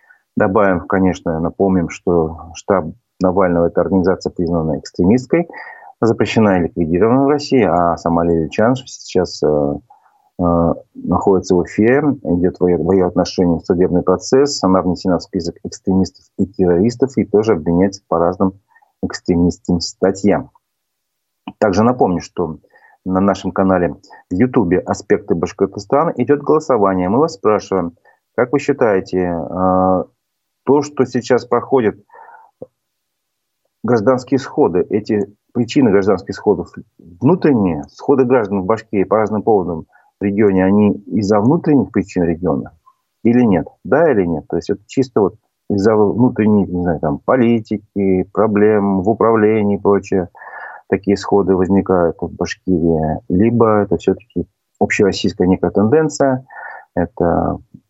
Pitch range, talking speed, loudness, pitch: 90-115 Hz, 130 wpm, -16 LUFS, 95 Hz